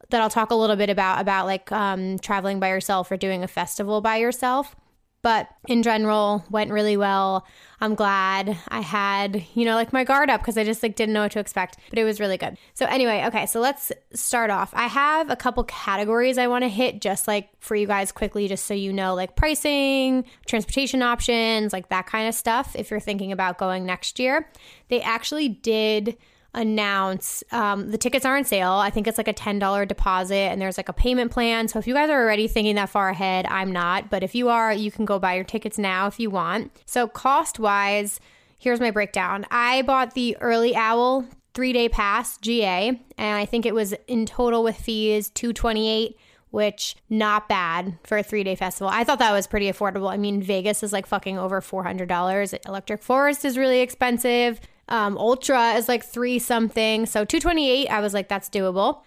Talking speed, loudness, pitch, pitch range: 215 wpm, -23 LUFS, 215 Hz, 195-240 Hz